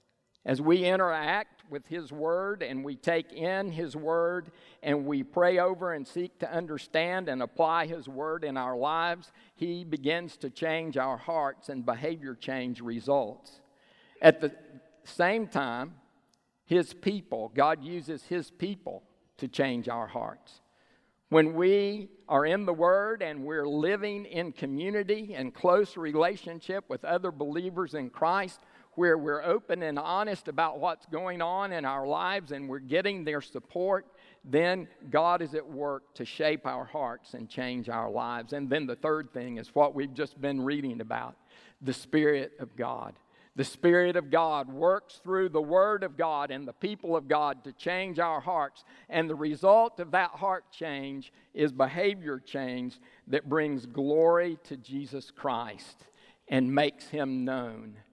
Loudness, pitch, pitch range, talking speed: -30 LUFS, 160 Hz, 140-180 Hz, 160 wpm